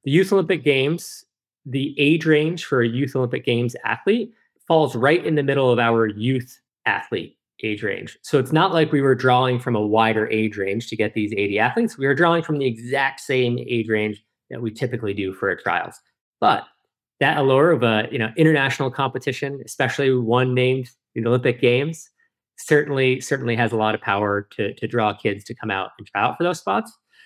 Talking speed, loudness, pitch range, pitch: 205 wpm, -21 LUFS, 115-150 Hz, 130 Hz